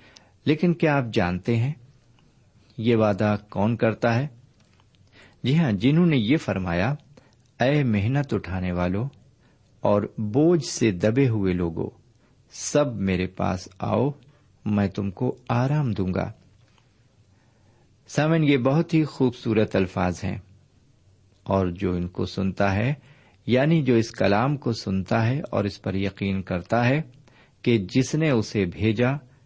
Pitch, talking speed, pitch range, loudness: 115 Hz, 135 wpm, 100-130 Hz, -24 LUFS